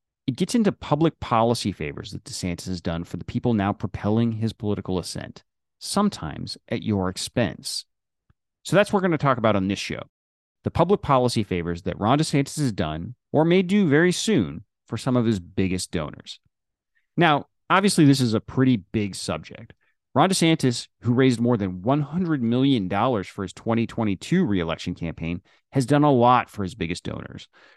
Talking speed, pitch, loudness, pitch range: 175 wpm, 115 Hz, -23 LUFS, 95-140 Hz